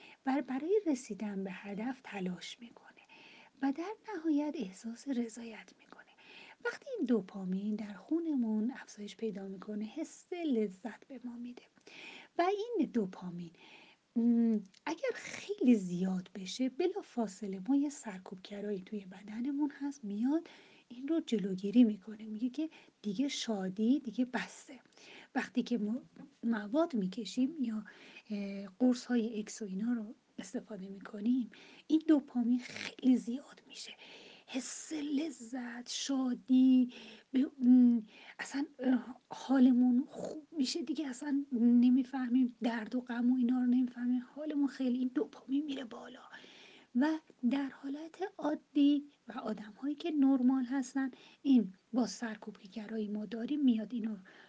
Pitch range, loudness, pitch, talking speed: 215-275 Hz, -34 LUFS, 245 Hz, 120 wpm